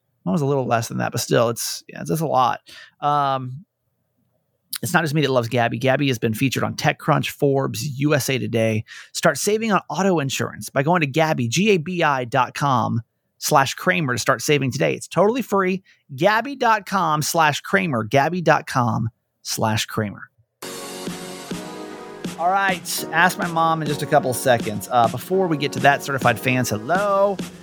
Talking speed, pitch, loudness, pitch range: 180 wpm, 140 Hz, -20 LUFS, 125-175 Hz